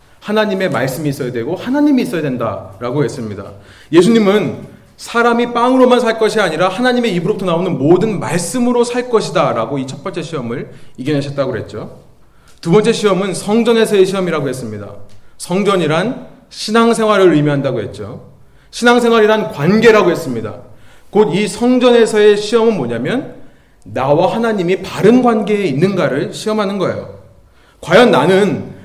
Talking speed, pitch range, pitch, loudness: 360 characters per minute, 140-220 Hz, 190 Hz, -13 LUFS